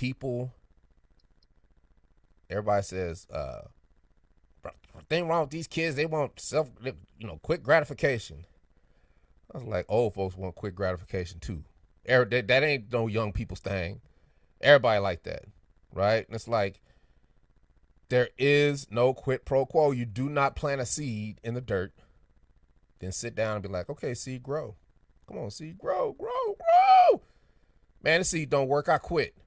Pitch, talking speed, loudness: 110 Hz, 155 wpm, -28 LUFS